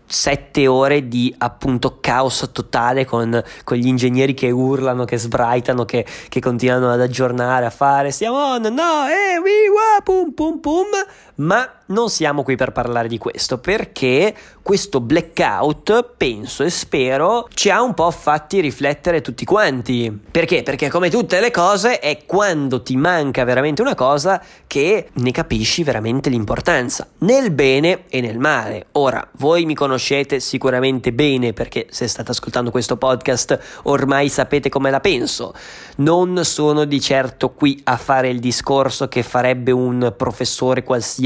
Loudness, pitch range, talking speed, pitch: -17 LUFS, 125-165 Hz, 155 wpm, 135 Hz